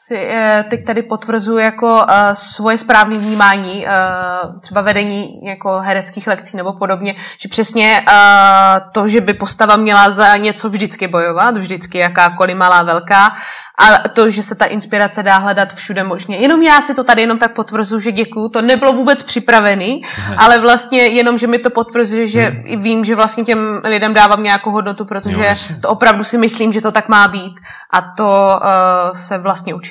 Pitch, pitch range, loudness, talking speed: 210 Hz, 195-225 Hz, -11 LUFS, 170 wpm